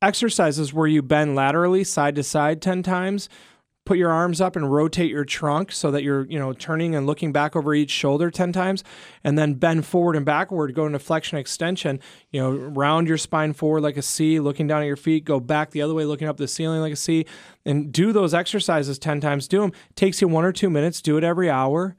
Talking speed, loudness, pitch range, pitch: 235 wpm, -22 LUFS, 150-175 Hz, 155 Hz